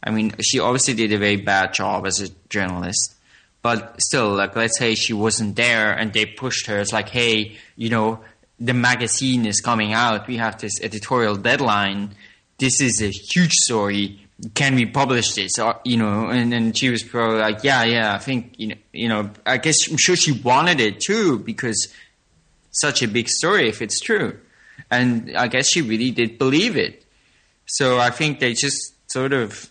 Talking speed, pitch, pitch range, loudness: 190 wpm, 115 Hz, 105-125 Hz, -19 LUFS